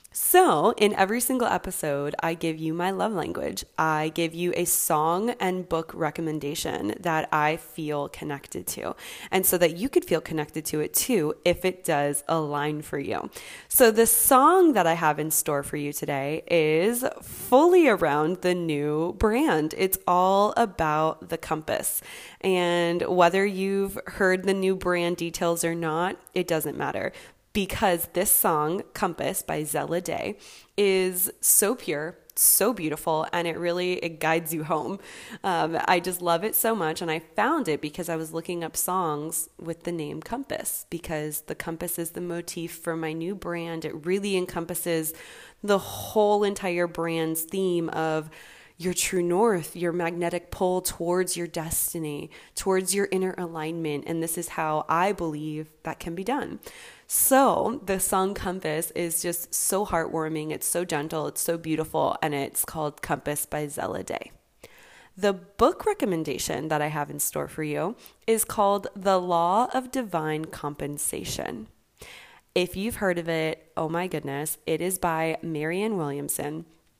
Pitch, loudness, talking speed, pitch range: 170 Hz, -25 LUFS, 160 wpm, 155-190 Hz